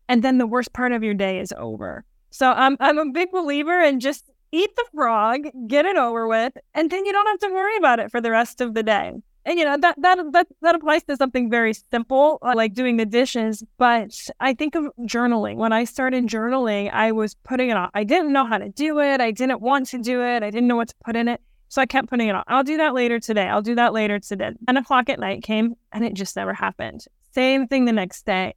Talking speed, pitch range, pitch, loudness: 260 wpm, 225-285 Hz, 250 Hz, -21 LUFS